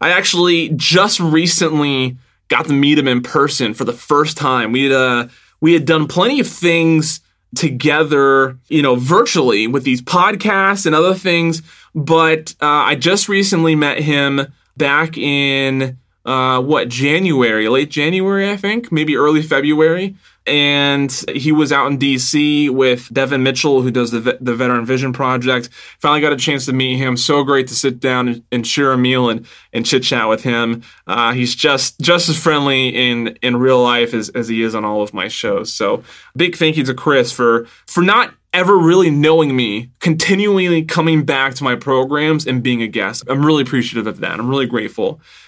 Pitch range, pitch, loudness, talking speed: 125-160 Hz, 140 Hz, -14 LUFS, 185 wpm